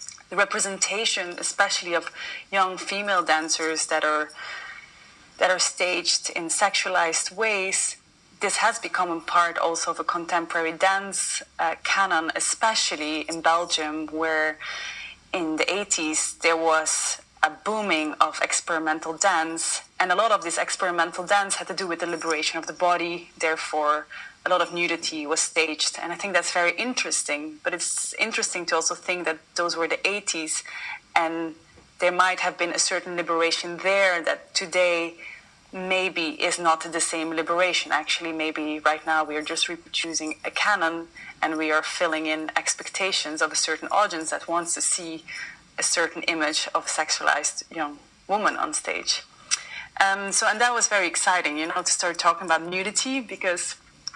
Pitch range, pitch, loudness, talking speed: 160-190 Hz, 175 Hz, -24 LUFS, 165 wpm